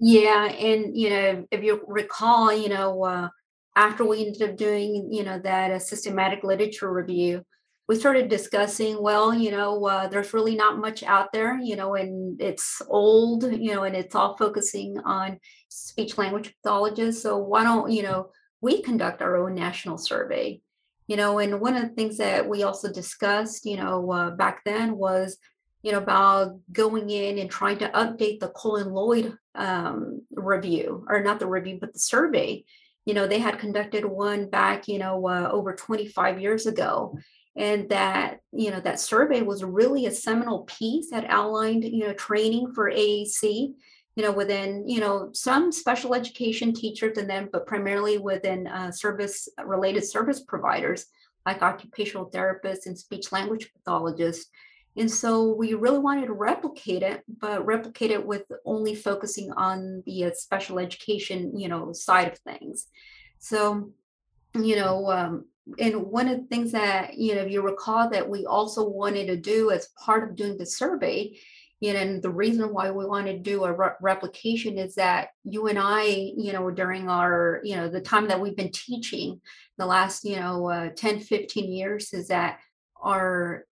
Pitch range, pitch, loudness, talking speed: 190-220 Hz, 205 Hz, -25 LUFS, 180 wpm